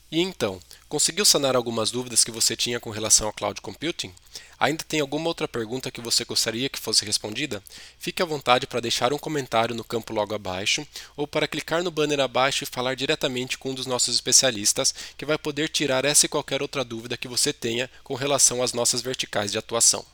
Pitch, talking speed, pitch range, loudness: 125 Hz, 205 wpm, 115-145 Hz, -23 LUFS